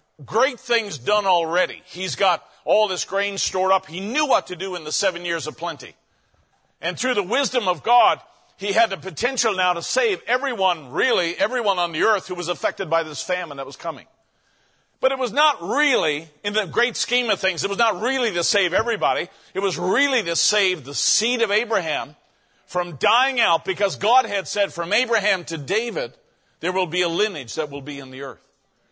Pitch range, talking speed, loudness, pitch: 175-230 Hz, 205 wpm, -21 LUFS, 195 Hz